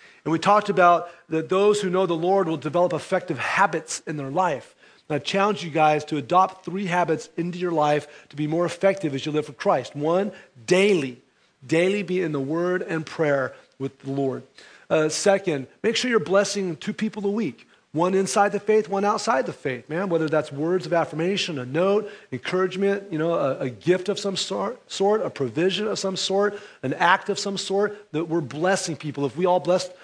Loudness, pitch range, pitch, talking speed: -23 LUFS, 155-195 Hz, 180 Hz, 200 wpm